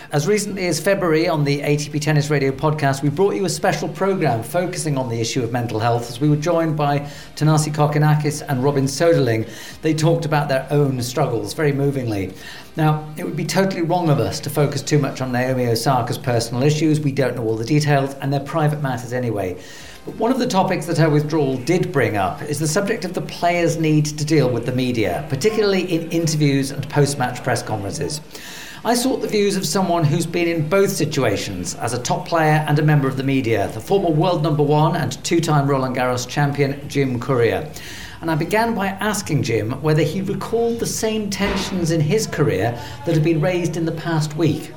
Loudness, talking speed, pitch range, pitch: -19 LUFS, 210 wpm, 135-170 Hz, 150 Hz